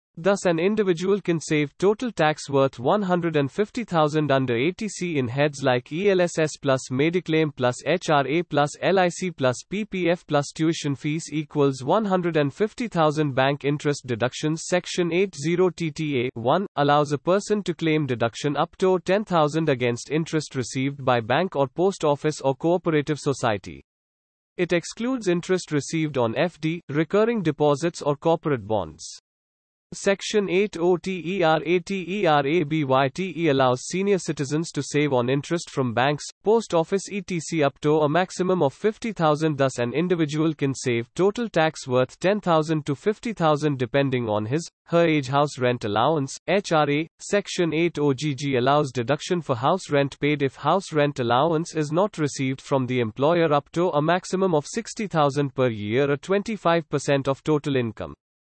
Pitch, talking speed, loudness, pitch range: 155 Hz, 140 wpm, -23 LUFS, 140-180 Hz